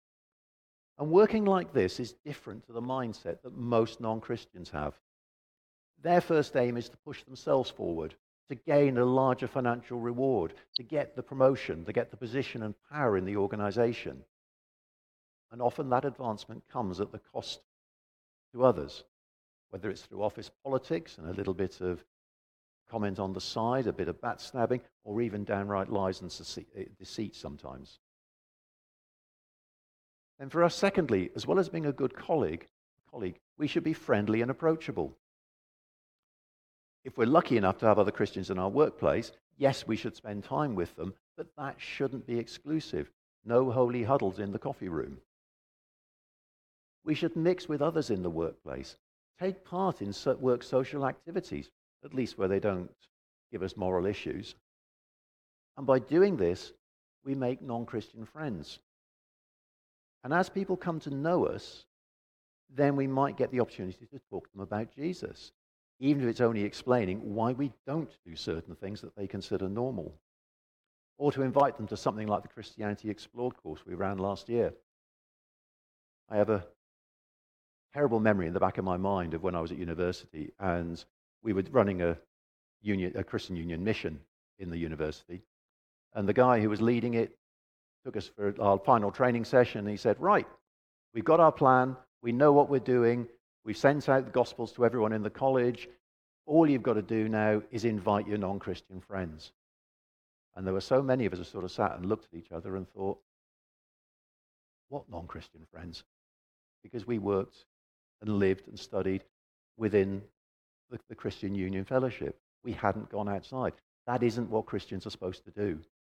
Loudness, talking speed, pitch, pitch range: -31 LUFS, 170 wpm, 110 Hz, 95-130 Hz